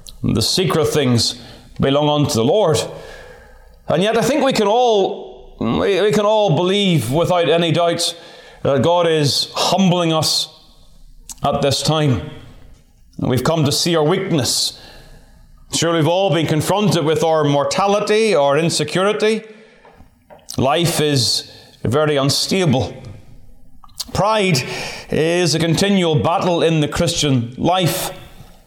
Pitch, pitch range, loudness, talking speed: 160 Hz, 140-185 Hz, -16 LUFS, 125 wpm